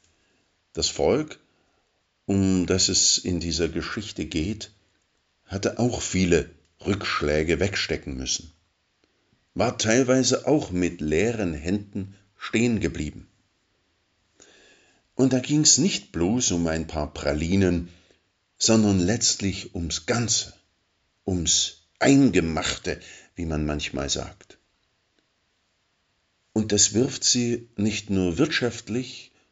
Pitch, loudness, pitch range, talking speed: 95 Hz, -23 LUFS, 85-115 Hz, 100 wpm